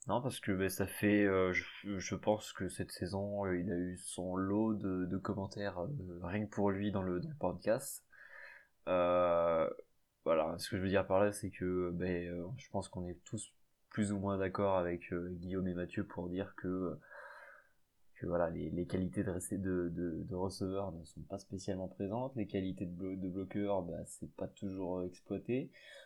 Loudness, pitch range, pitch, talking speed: -38 LUFS, 90-100 Hz, 95 Hz, 205 wpm